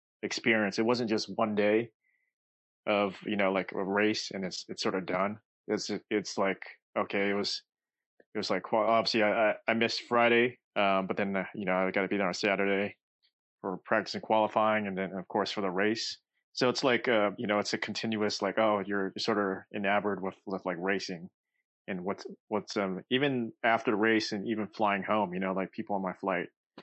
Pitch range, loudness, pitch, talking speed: 95-110 Hz, -30 LUFS, 105 Hz, 210 wpm